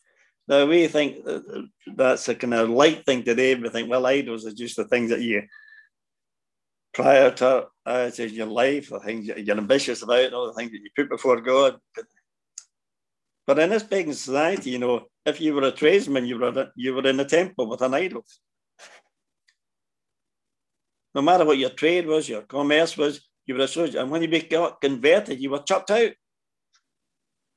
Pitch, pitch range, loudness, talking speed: 135 Hz, 125-155 Hz, -22 LUFS, 180 wpm